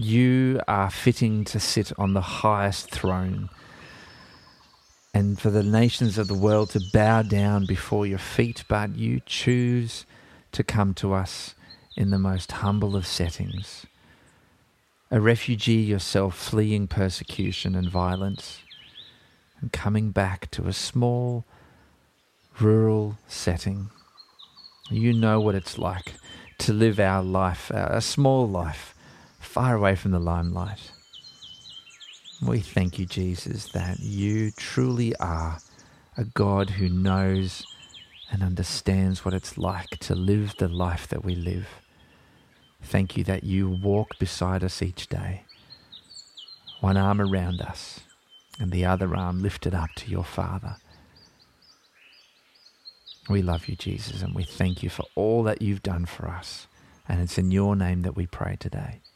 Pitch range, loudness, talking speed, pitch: 90-105 Hz, -25 LUFS, 140 wpm, 95 Hz